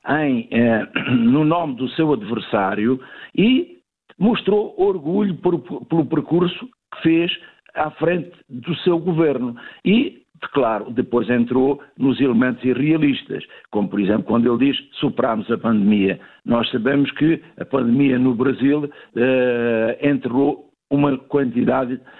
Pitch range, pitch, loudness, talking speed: 120-160 Hz, 135 Hz, -19 LUFS, 130 wpm